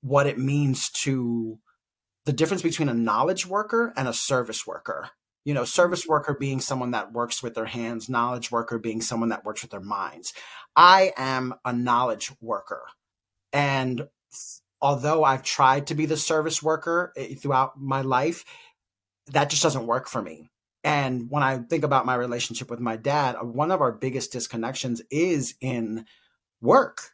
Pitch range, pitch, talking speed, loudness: 120-150 Hz, 130 Hz, 165 wpm, -24 LUFS